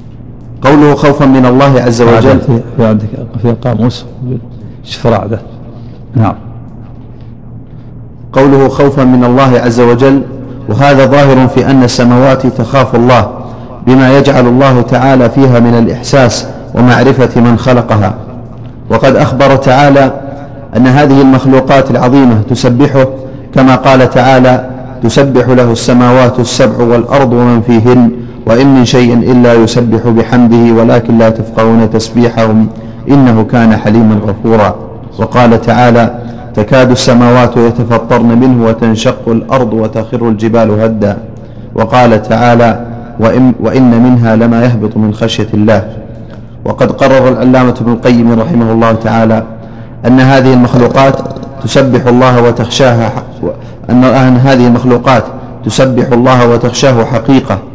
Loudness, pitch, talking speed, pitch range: -7 LUFS, 120 Hz, 105 wpm, 115-130 Hz